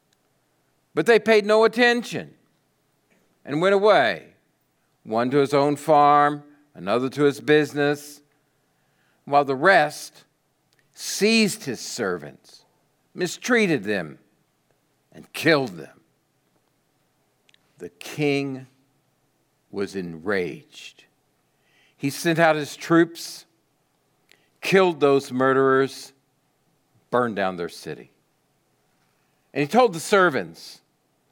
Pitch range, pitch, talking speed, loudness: 135-165 Hz, 145 Hz, 95 wpm, -21 LUFS